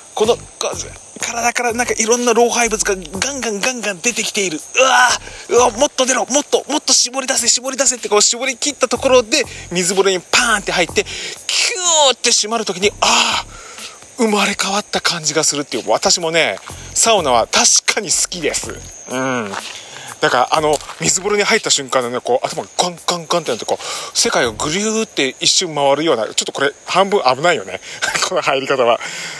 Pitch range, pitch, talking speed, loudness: 185-255 Hz, 220 Hz, 385 characters per minute, -15 LUFS